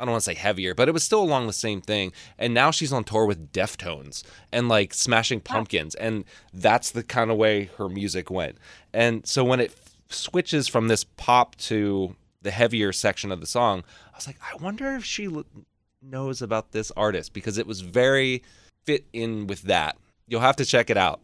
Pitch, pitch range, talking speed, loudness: 110 Hz, 100-125 Hz, 210 wpm, -24 LUFS